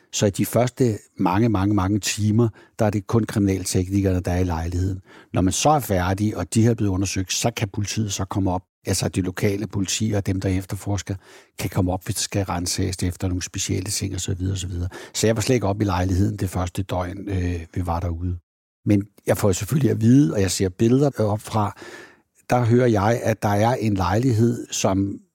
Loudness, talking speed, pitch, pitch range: -22 LUFS, 220 wpm, 100 Hz, 95-110 Hz